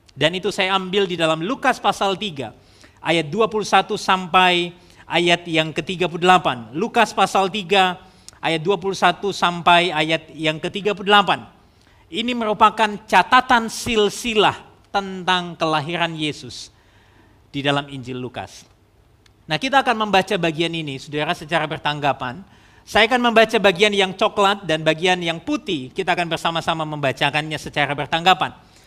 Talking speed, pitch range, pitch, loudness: 125 wpm, 150-200 Hz, 175 Hz, -19 LUFS